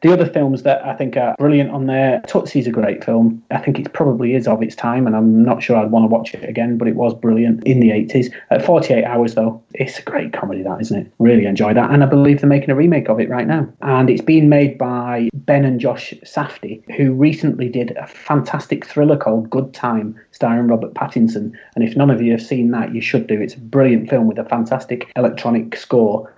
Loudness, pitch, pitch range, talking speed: -16 LUFS, 120 Hz, 115-135 Hz, 240 wpm